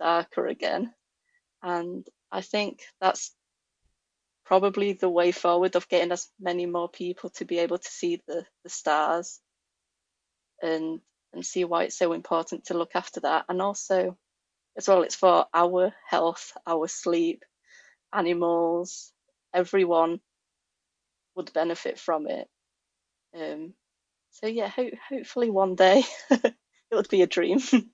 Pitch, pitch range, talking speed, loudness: 180 Hz, 170-200 Hz, 135 wpm, -26 LUFS